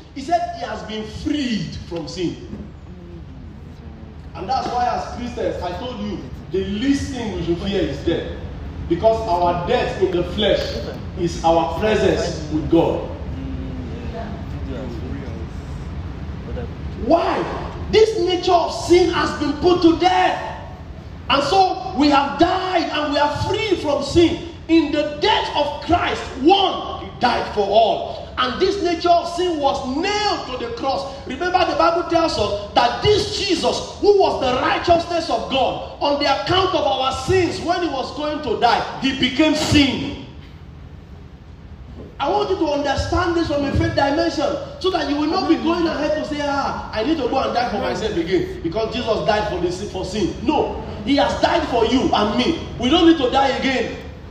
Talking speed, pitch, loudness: 170 wpm, 285 Hz, -19 LUFS